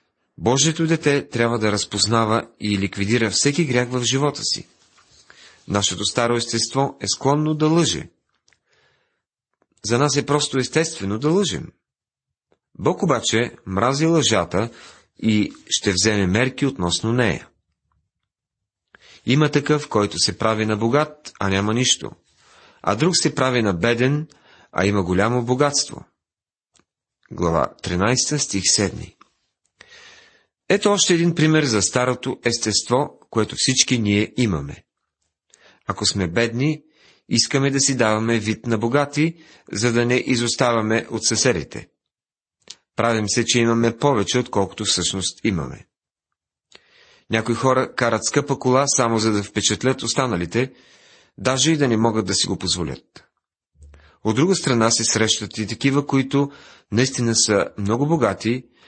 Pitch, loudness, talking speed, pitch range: 120 Hz, -20 LUFS, 130 wpm, 105-140 Hz